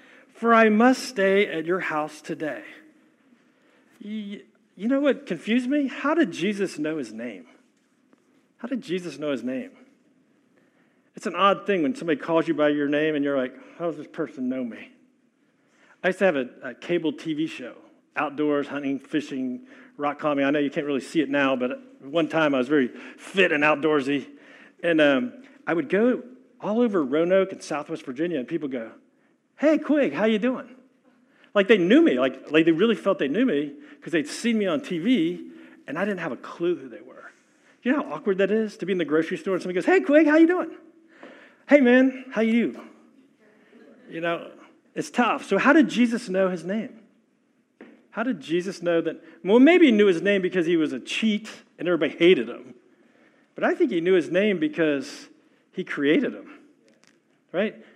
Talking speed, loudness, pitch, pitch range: 195 wpm, -23 LUFS, 235 Hz, 170-275 Hz